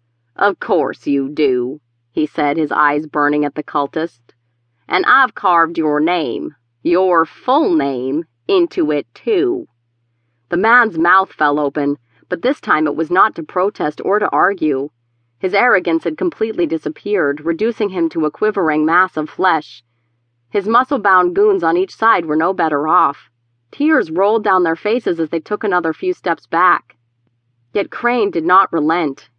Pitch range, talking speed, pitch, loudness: 135-205 Hz, 165 wpm, 160 Hz, -16 LUFS